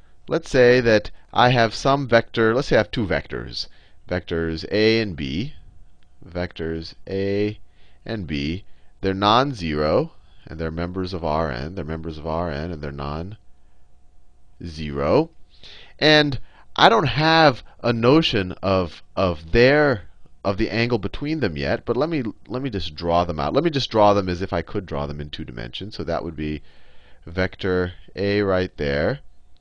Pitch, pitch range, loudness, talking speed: 90 Hz, 80-110 Hz, -21 LUFS, 170 wpm